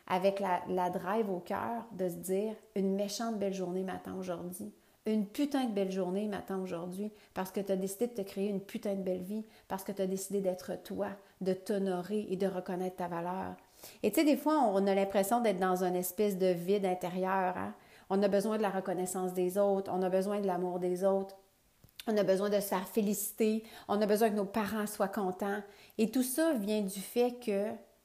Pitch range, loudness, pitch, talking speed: 185-210 Hz, -34 LUFS, 195 Hz, 220 wpm